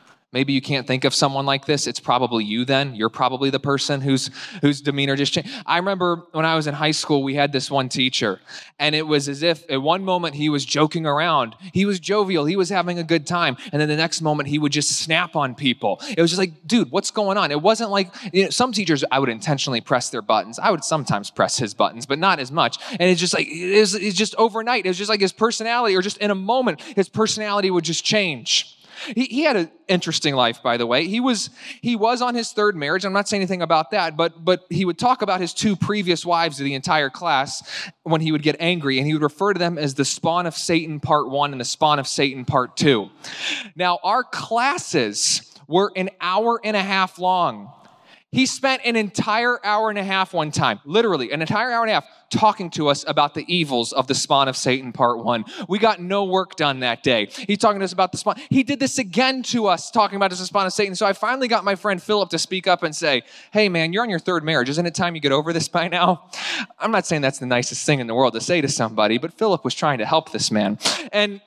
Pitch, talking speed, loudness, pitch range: 170 Hz, 250 wpm, -20 LUFS, 145-205 Hz